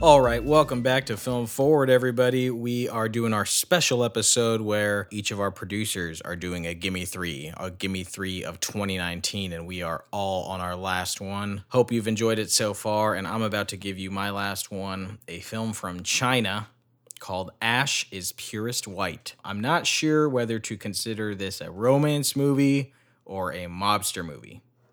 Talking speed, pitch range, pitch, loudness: 180 wpm, 95-120 Hz, 105 Hz, -25 LUFS